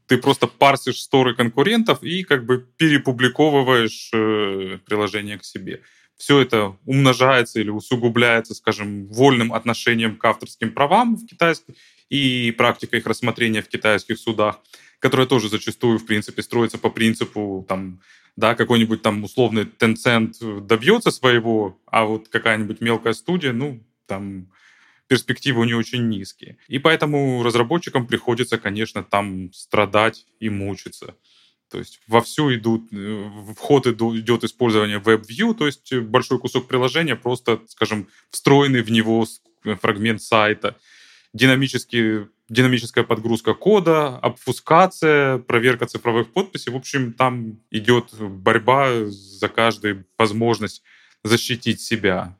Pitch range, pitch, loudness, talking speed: 110-130 Hz, 115 Hz, -19 LUFS, 125 wpm